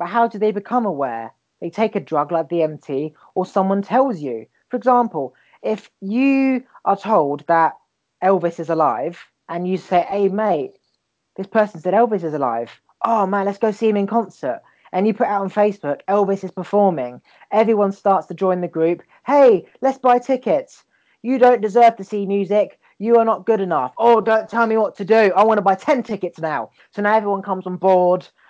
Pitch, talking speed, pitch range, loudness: 200 Hz, 200 wpm, 180-225 Hz, -19 LUFS